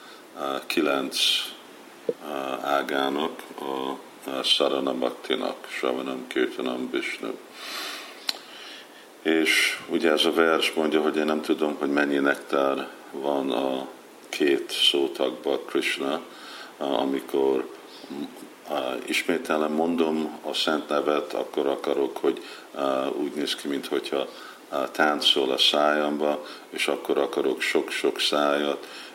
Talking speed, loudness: 110 wpm, -25 LUFS